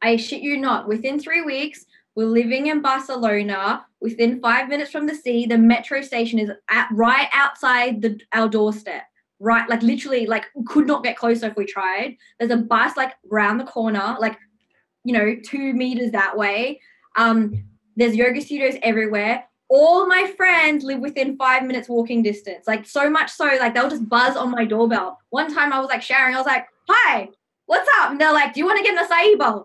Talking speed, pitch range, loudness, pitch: 200 wpm, 225-280 Hz, -19 LUFS, 245 Hz